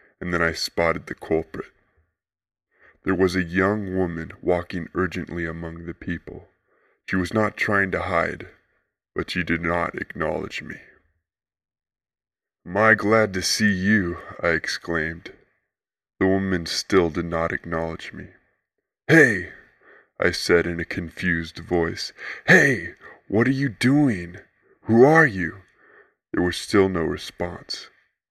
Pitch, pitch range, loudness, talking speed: 90 Hz, 85-95 Hz, -22 LUFS, 130 wpm